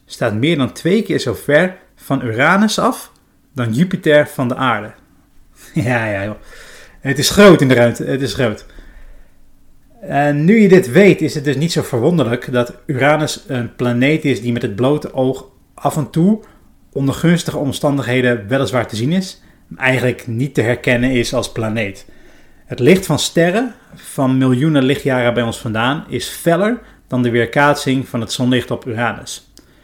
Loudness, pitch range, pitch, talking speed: -15 LUFS, 120-155 Hz, 135 Hz, 175 wpm